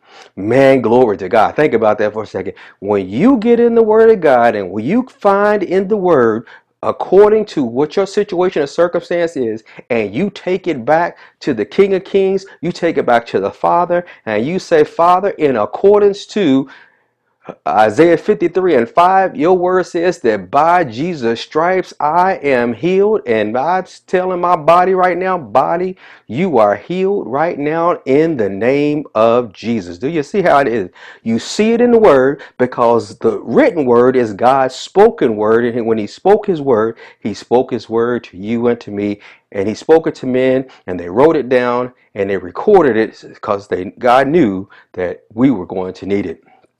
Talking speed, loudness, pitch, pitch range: 190 wpm, -14 LUFS, 155 Hz, 115-185 Hz